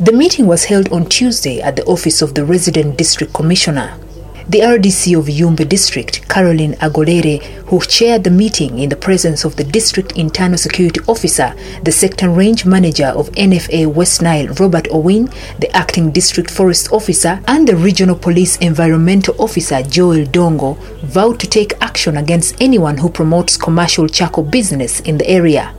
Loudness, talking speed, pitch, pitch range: -11 LUFS, 165 wpm, 175 Hz, 155-190 Hz